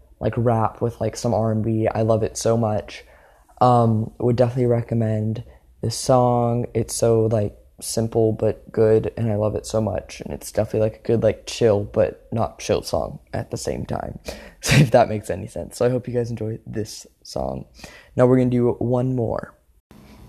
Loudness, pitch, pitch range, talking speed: -21 LUFS, 110 Hz, 110-120 Hz, 190 wpm